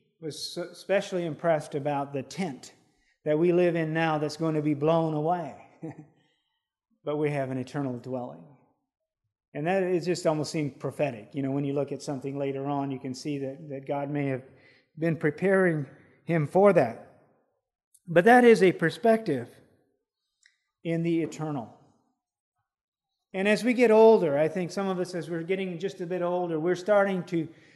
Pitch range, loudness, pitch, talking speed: 145-180 Hz, -26 LUFS, 160 Hz, 175 wpm